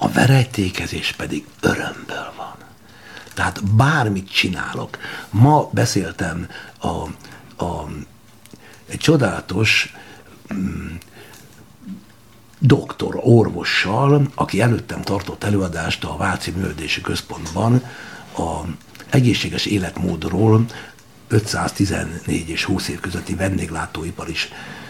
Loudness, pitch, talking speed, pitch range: -20 LUFS, 95 Hz, 85 wpm, 85-110 Hz